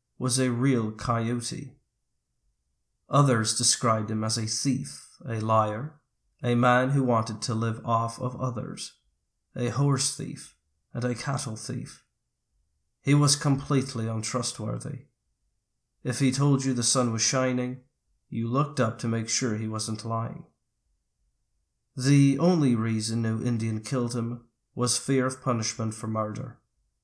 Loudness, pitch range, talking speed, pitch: -26 LUFS, 110-130 Hz, 140 wpm, 120 Hz